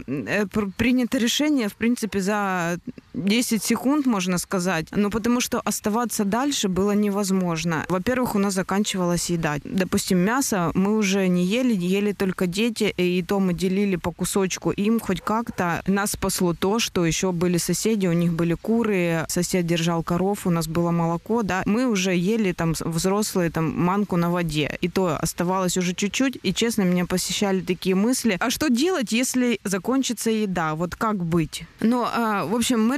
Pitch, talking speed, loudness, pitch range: 195 Hz, 165 wpm, -23 LUFS, 180-225 Hz